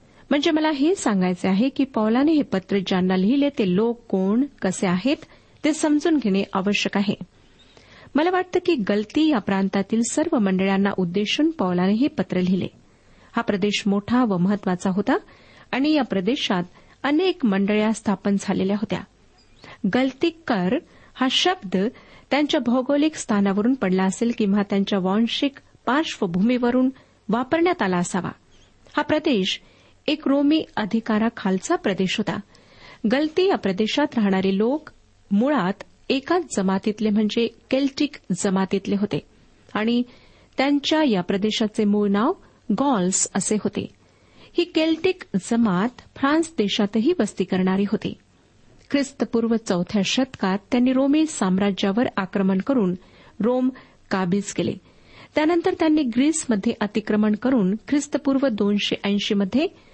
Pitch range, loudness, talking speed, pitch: 200-280 Hz, -22 LUFS, 125 wpm, 220 Hz